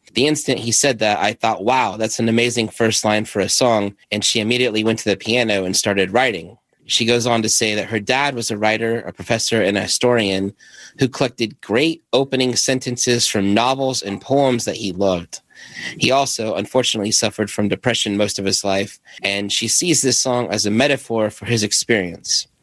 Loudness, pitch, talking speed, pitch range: -18 LUFS, 115 Hz, 200 wpm, 105-125 Hz